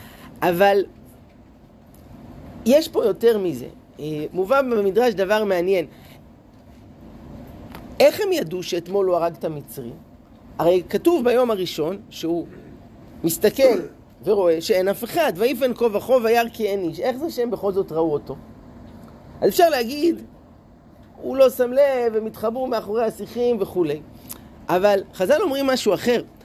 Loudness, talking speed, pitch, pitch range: -21 LUFS, 135 wpm, 215 Hz, 175-255 Hz